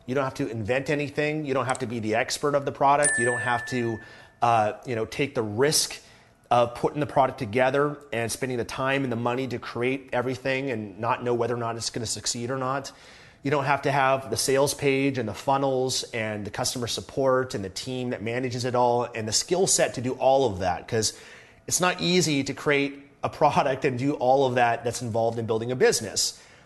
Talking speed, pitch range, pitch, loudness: 230 wpm, 120-140 Hz, 130 Hz, -25 LUFS